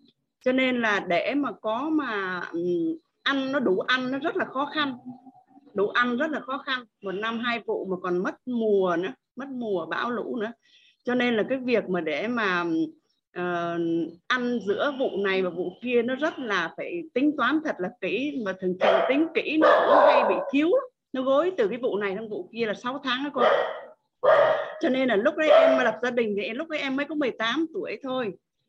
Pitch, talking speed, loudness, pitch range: 255 Hz, 220 wpm, -25 LUFS, 205-300 Hz